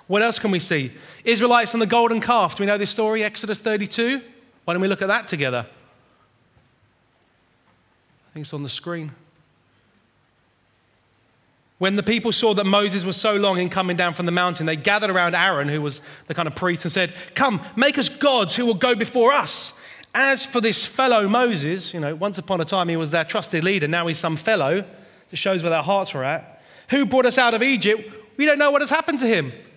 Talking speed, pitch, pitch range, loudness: 215 wpm, 195 Hz, 170-230 Hz, -20 LUFS